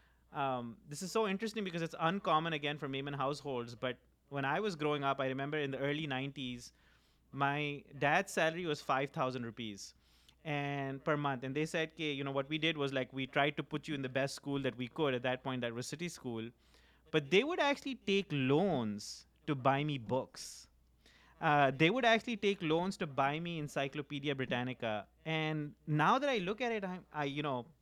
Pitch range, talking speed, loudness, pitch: 130-160 Hz, 195 wpm, -36 LUFS, 140 Hz